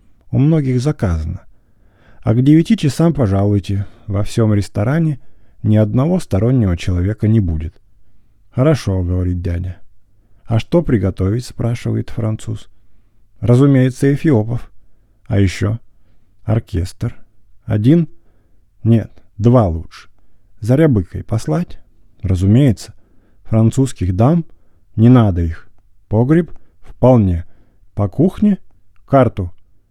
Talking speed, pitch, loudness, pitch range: 95 wpm, 105 Hz, -16 LUFS, 100-120 Hz